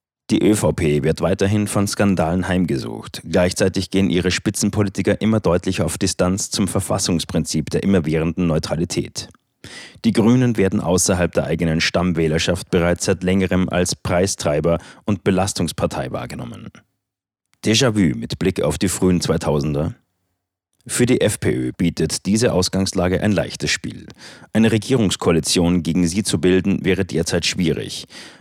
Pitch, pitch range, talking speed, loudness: 90 Hz, 85-100 Hz, 130 wpm, -19 LUFS